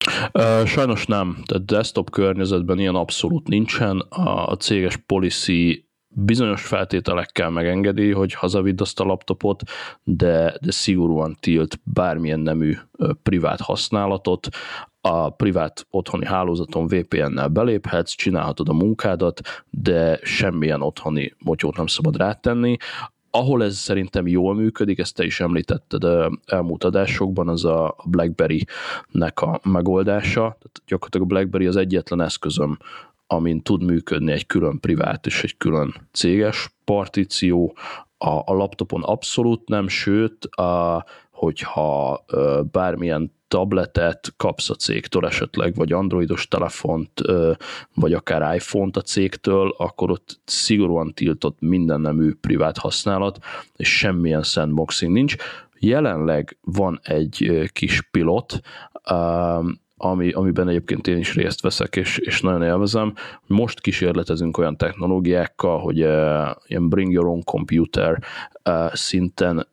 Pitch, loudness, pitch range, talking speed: 90 Hz, -21 LUFS, 85-100 Hz, 120 wpm